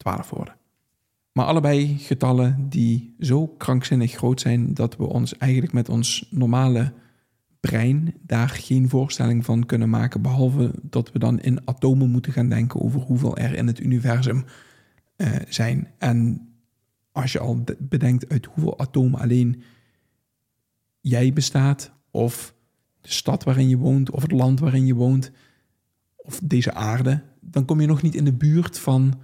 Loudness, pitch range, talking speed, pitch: -21 LUFS, 120-135 Hz, 155 wpm, 130 Hz